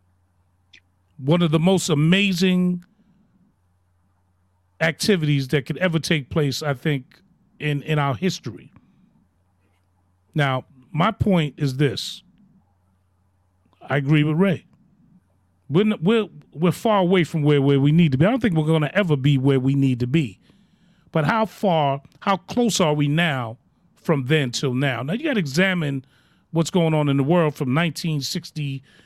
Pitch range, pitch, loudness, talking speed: 130-180 Hz, 150 Hz, -21 LUFS, 160 wpm